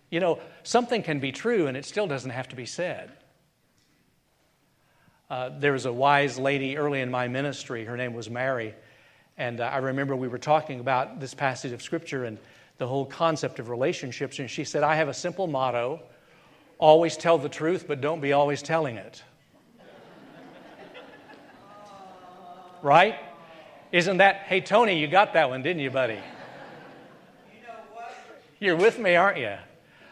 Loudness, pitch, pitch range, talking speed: -25 LUFS, 145 Hz, 130-175 Hz, 160 wpm